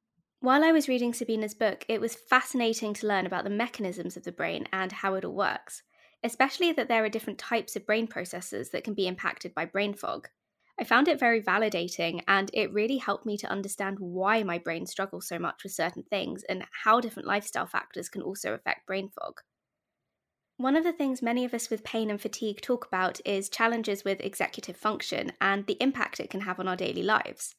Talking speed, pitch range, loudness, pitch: 210 wpm, 195-235 Hz, -29 LUFS, 215 Hz